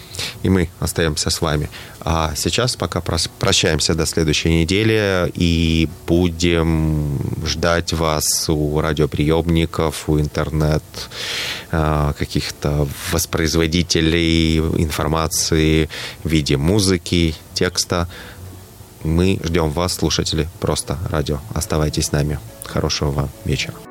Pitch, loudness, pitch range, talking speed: 80 Hz, -19 LUFS, 80-90 Hz, 100 wpm